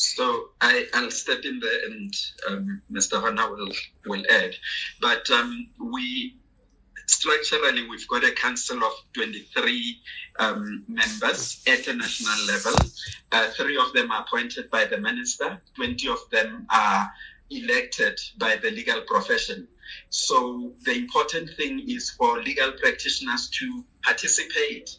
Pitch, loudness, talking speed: 245 Hz, -24 LUFS, 135 wpm